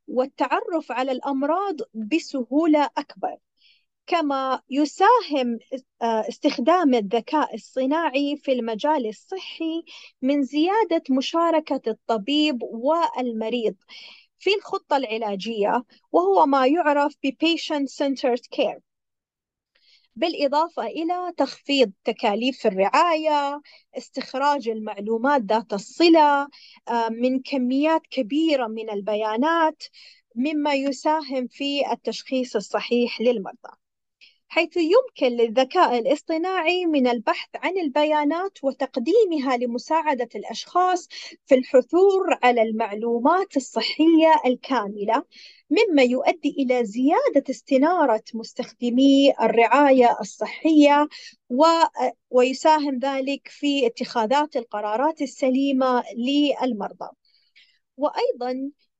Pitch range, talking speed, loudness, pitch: 245-315 Hz, 80 wpm, -22 LUFS, 275 Hz